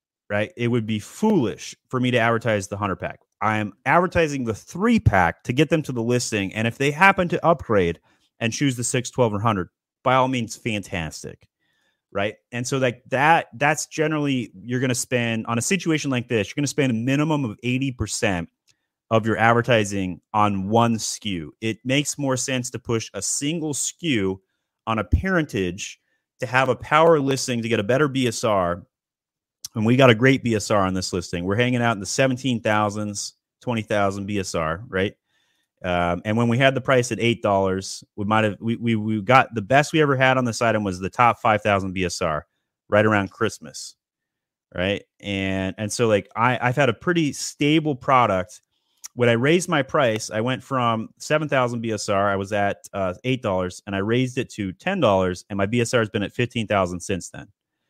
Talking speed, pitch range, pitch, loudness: 195 wpm, 100-130 Hz, 115 Hz, -22 LUFS